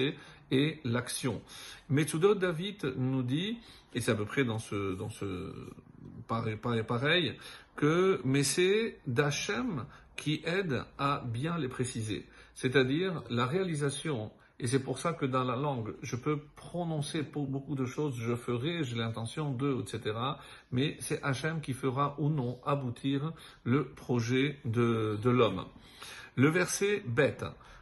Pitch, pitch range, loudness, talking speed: 140 Hz, 120-150 Hz, -32 LUFS, 145 wpm